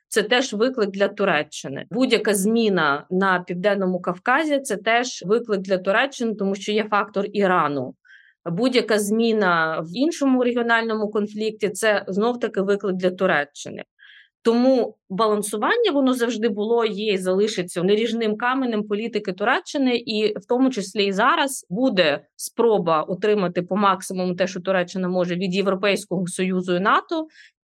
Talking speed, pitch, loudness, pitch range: 135 wpm, 210 Hz, -21 LUFS, 190-230 Hz